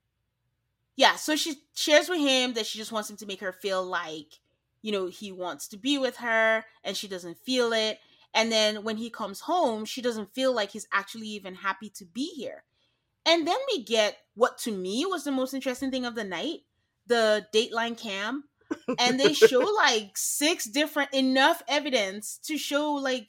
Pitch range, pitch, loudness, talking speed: 210-285 Hz, 230 Hz, -26 LUFS, 195 wpm